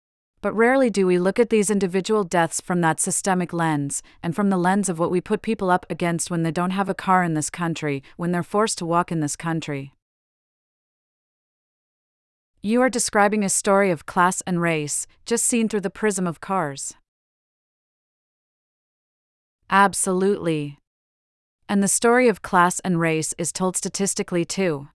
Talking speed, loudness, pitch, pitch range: 165 wpm, -21 LUFS, 180 Hz, 165-200 Hz